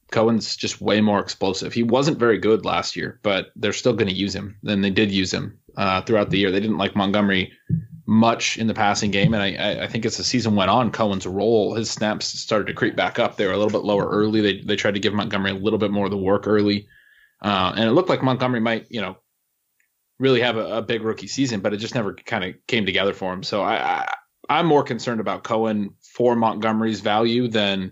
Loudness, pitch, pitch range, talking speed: -21 LUFS, 110 Hz, 100-115 Hz, 245 wpm